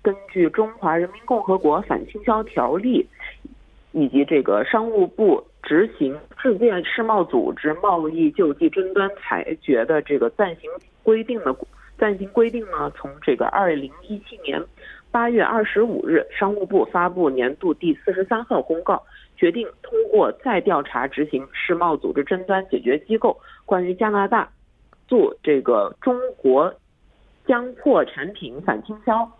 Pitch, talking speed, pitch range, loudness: 220 Hz, 235 characters per minute, 190-265 Hz, -21 LUFS